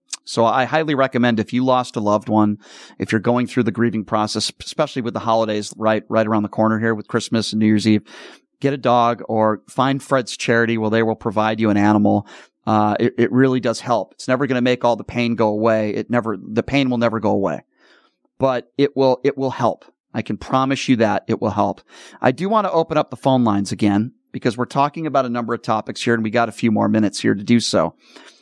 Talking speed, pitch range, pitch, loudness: 245 wpm, 110-130 Hz, 115 Hz, -19 LUFS